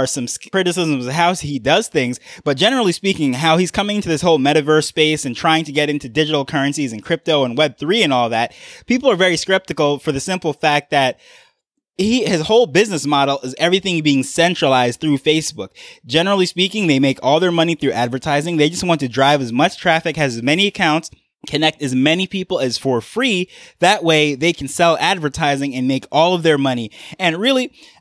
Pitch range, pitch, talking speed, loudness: 140-180 Hz, 155 Hz, 200 wpm, -16 LUFS